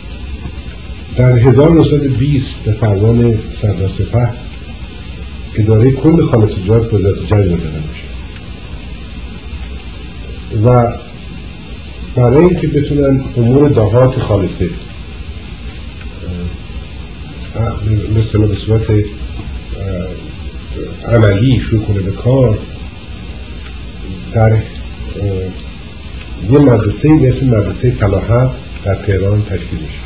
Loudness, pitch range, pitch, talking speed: -12 LUFS, 80-115 Hz, 95 Hz, 75 wpm